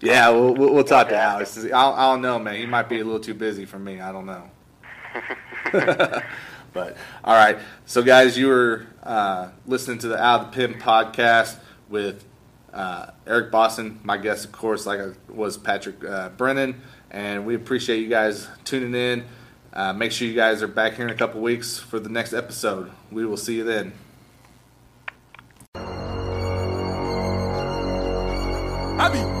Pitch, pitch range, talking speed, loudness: 110 Hz, 100-120 Hz, 165 wpm, -21 LUFS